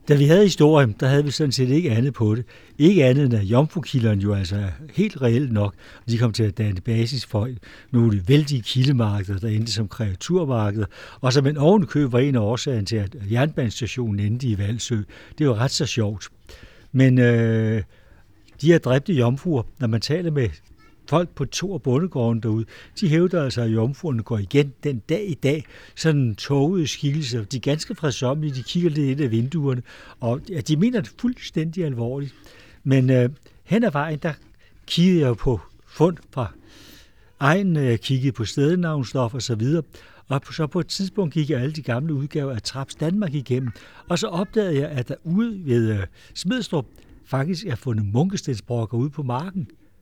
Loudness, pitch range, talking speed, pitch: -22 LUFS, 115-155 Hz, 185 wpm, 130 Hz